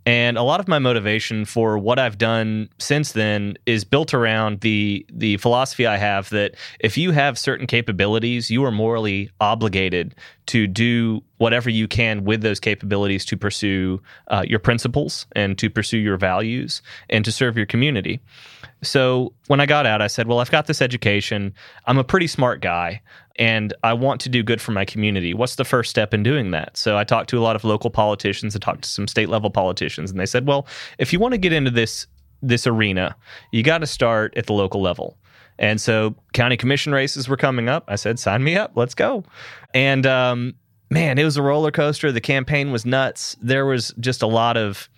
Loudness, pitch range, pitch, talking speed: -20 LUFS, 105-130 Hz, 115 Hz, 210 wpm